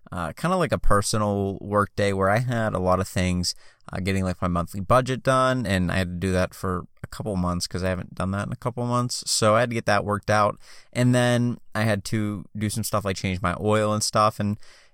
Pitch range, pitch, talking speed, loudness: 95-115 Hz, 105 Hz, 255 wpm, -24 LUFS